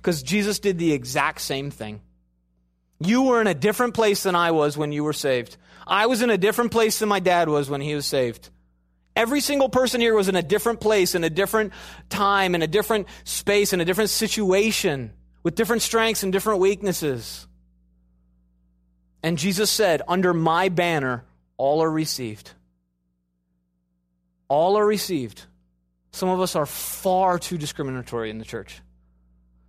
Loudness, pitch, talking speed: -22 LUFS, 160 Hz, 170 wpm